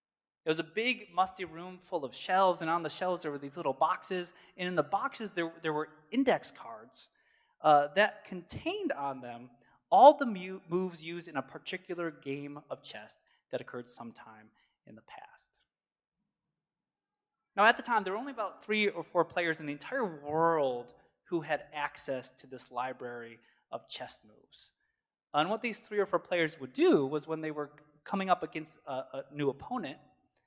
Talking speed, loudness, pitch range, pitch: 185 wpm, -32 LUFS, 145-185 Hz, 165 Hz